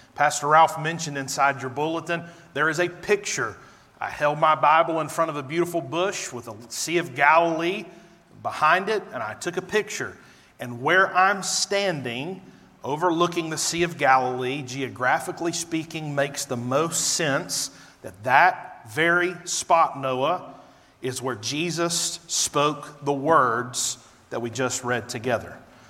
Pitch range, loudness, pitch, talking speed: 130-170 Hz, -23 LUFS, 155 Hz, 145 wpm